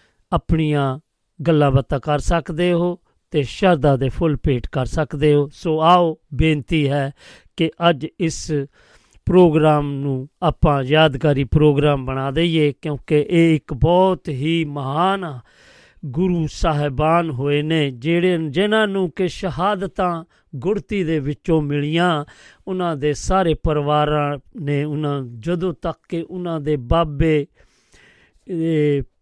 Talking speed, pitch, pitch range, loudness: 120 wpm, 155 Hz, 145-170 Hz, -19 LUFS